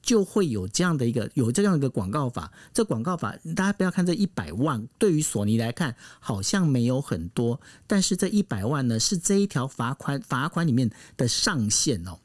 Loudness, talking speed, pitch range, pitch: -25 LUFS, 305 characters per minute, 115-180 Hz, 135 Hz